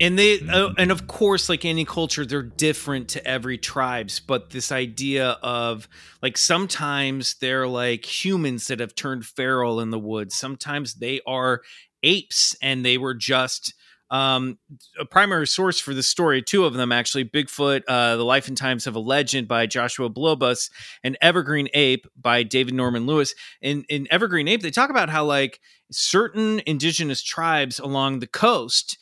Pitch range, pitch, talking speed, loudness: 125-155 Hz, 135 Hz, 170 wpm, -21 LUFS